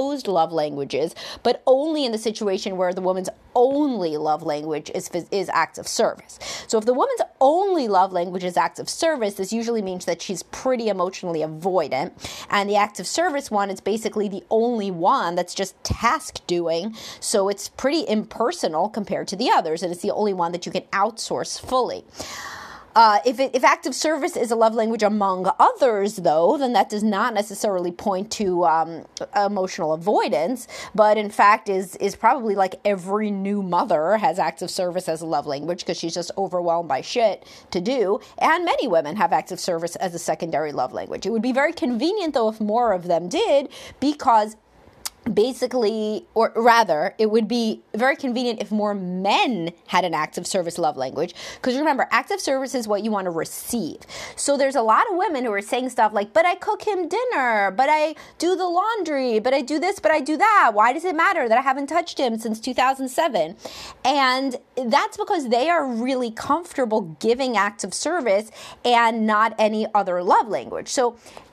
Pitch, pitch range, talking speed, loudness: 220 Hz, 190-265 Hz, 190 wpm, -22 LUFS